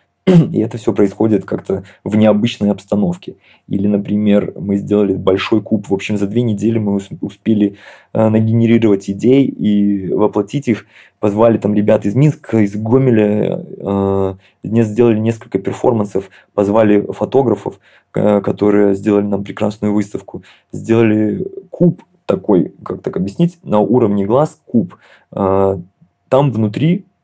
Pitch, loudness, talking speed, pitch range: 105 Hz, -15 LUFS, 130 wpm, 100-115 Hz